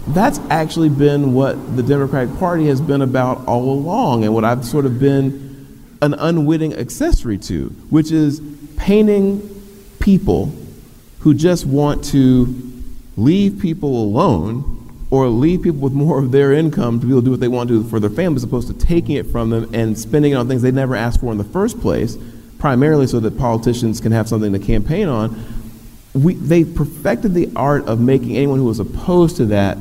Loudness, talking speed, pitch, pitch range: -16 LUFS, 195 wpm, 135 Hz, 120-155 Hz